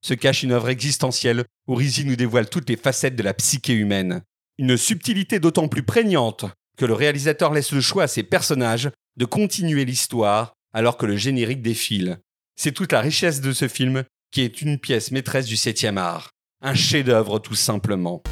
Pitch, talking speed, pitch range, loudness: 130 Hz, 185 wpm, 110-145 Hz, -21 LUFS